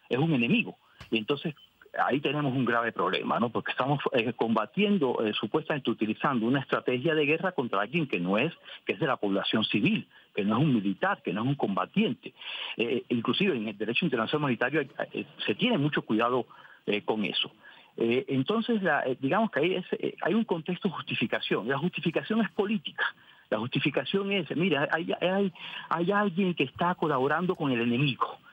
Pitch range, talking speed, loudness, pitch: 130-185 Hz, 190 wpm, -28 LUFS, 155 Hz